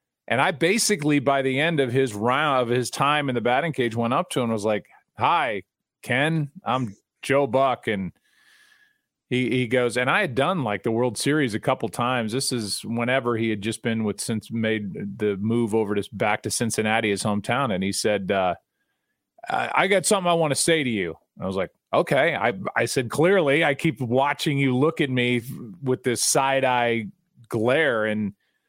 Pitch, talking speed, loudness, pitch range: 125 Hz, 200 wpm, -23 LUFS, 115-145 Hz